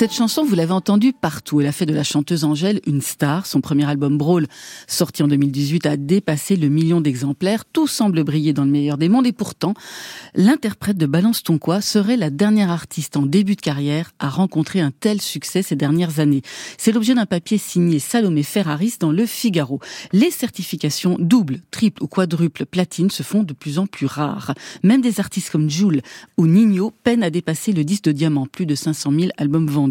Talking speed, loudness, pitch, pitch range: 205 wpm, -19 LUFS, 170 Hz, 150-205 Hz